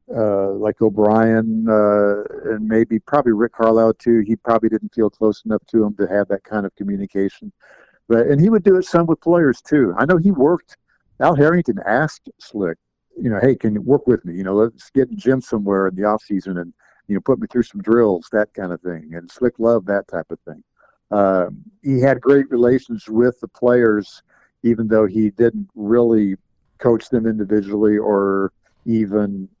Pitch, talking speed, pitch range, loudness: 110 Hz, 200 wpm, 105-120 Hz, -18 LUFS